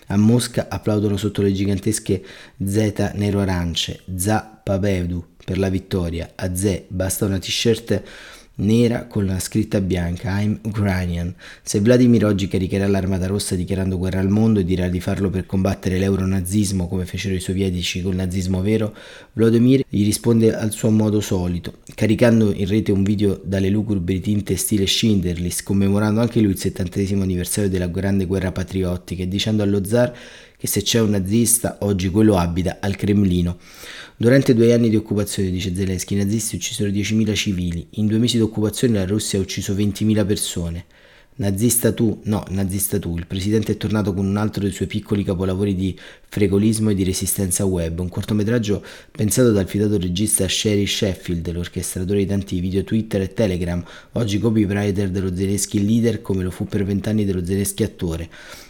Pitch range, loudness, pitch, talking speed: 95-105 Hz, -20 LUFS, 100 Hz, 170 wpm